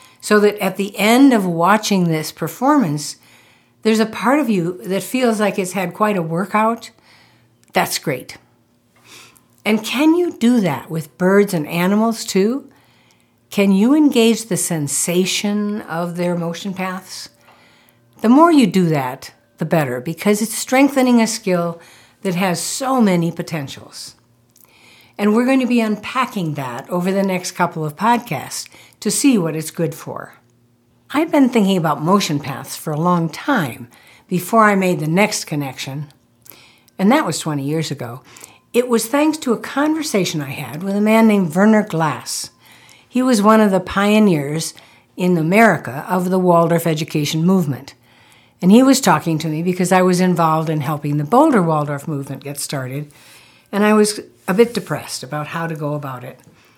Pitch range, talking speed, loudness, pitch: 150-215 Hz, 165 wpm, -17 LUFS, 180 Hz